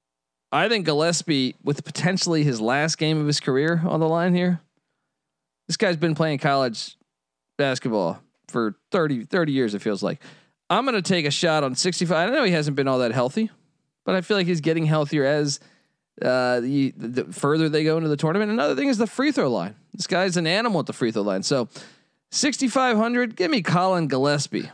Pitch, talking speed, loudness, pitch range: 155 Hz, 200 wpm, -22 LUFS, 140-180 Hz